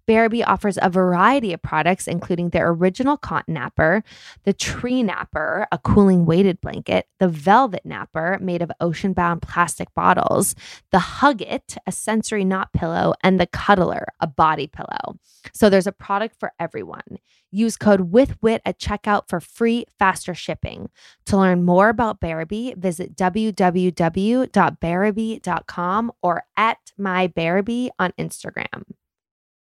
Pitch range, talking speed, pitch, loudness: 175-215 Hz, 130 wpm, 190 Hz, -20 LUFS